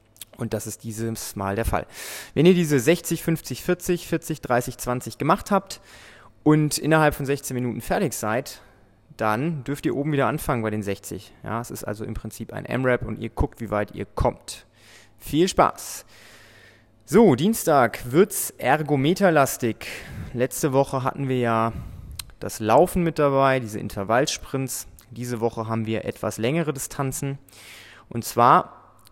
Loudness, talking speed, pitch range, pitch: -23 LUFS, 155 wpm, 110-150 Hz, 125 Hz